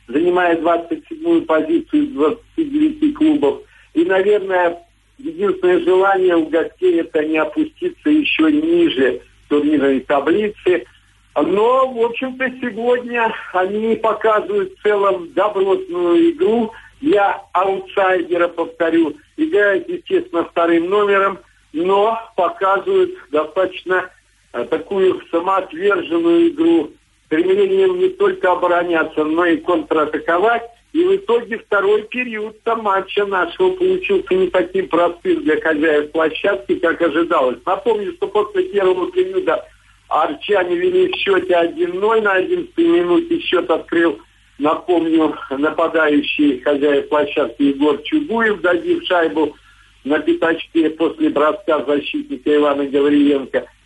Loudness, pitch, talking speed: -17 LUFS, 210 Hz, 105 wpm